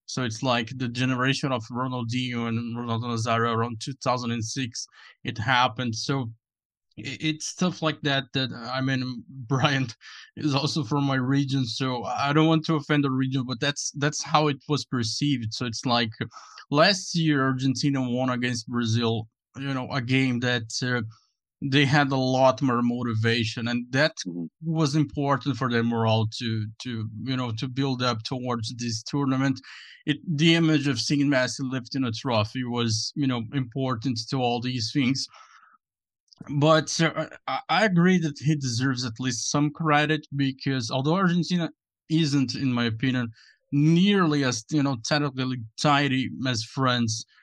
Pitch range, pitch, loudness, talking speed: 120-145 Hz, 130 Hz, -25 LUFS, 160 wpm